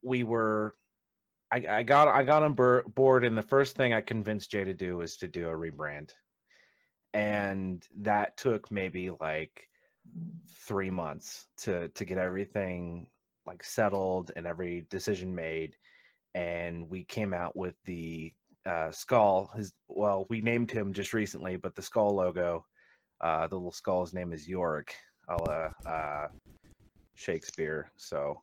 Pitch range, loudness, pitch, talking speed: 85-110 Hz, -32 LUFS, 95 Hz, 150 wpm